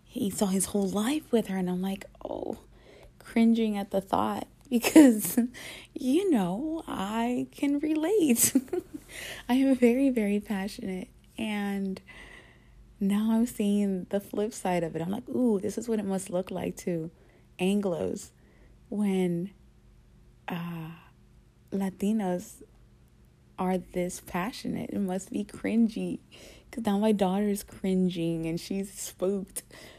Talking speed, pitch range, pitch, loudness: 130 wpm, 185-235 Hz, 205 Hz, -28 LUFS